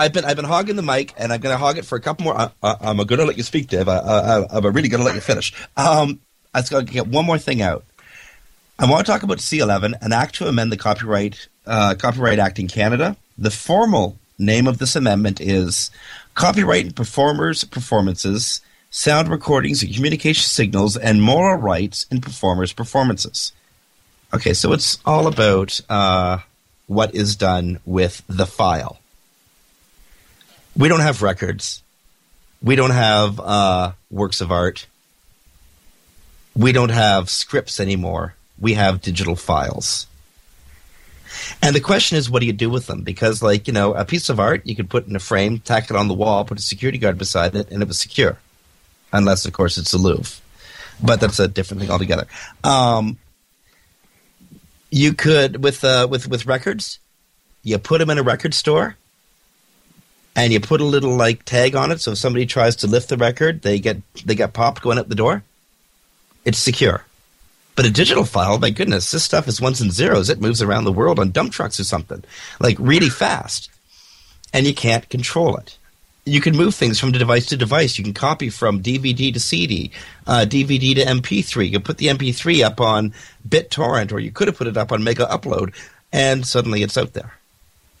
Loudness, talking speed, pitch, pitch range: -18 LUFS, 190 wpm, 115 Hz, 100-135 Hz